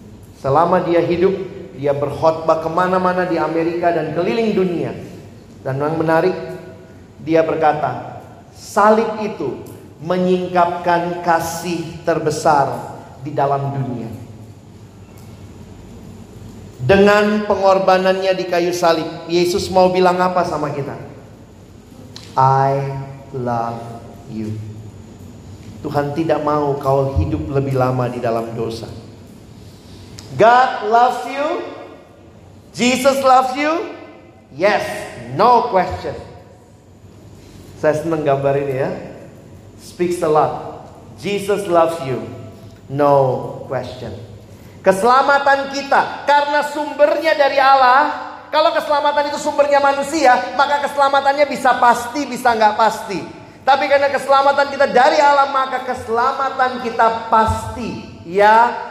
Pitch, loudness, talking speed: 165 Hz, -16 LUFS, 100 wpm